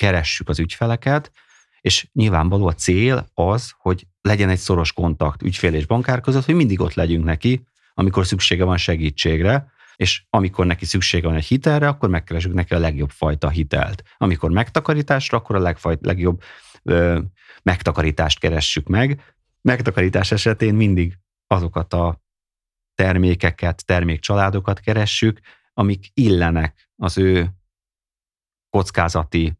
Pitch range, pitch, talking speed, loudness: 85-105 Hz, 90 Hz, 130 wpm, -19 LUFS